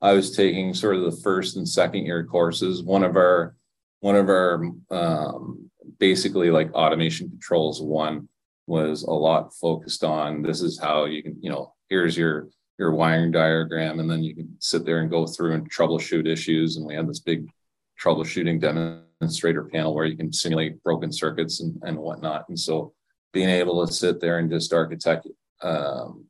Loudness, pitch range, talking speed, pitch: -23 LUFS, 80-85 Hz, 185 wpm, 80 Hz